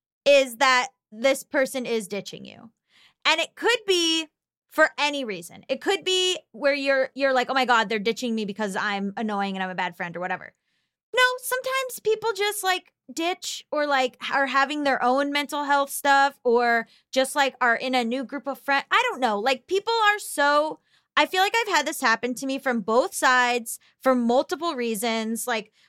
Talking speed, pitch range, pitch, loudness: 195 wpm, 235-315 Hz, 270 Hz, -23 LUFS